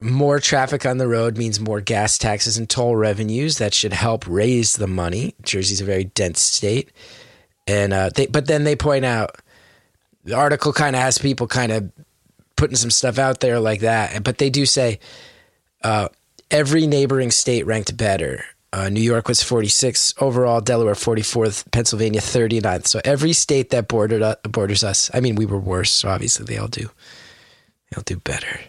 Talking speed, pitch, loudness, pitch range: 180 wpm, 115 Hz, -18 LUFS, 105-135 Hz